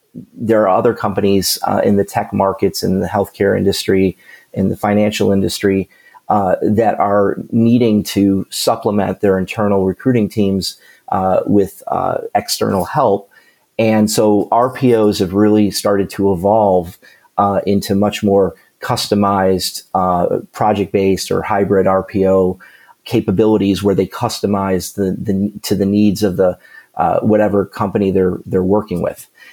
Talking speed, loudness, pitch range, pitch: 140 wpm, -15 LUFS, 95-105 Hz, 100 Hz